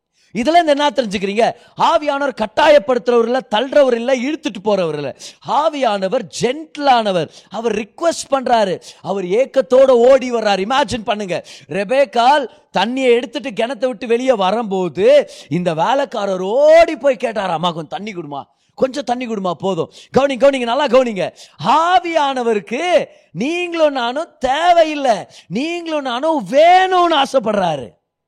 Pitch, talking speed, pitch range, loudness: 255 Hz, 120 wpm, 215-290 Hz, -16 LUFS